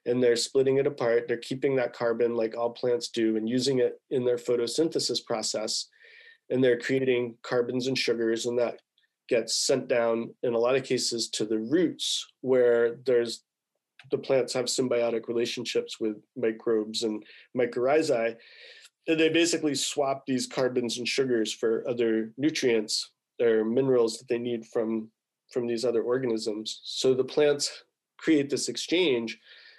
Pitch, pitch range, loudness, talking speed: 120 Hz, 115-130 Hz, -27 LUFS, 155 wpm